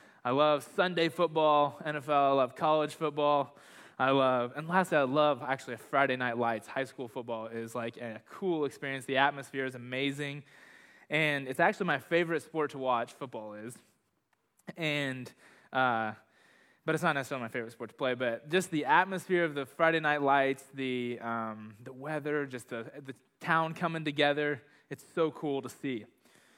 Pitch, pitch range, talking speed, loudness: 140 Hz, 125-150 Hz, 170 wpm, -31 LUFS